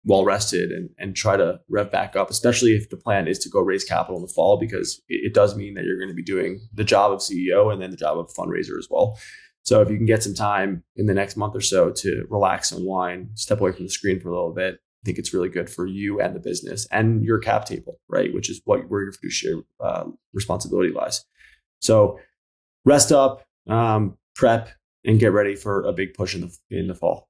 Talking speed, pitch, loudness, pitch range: 245 wpm, 105 Hz, -22 LUFS, 95-115 Hz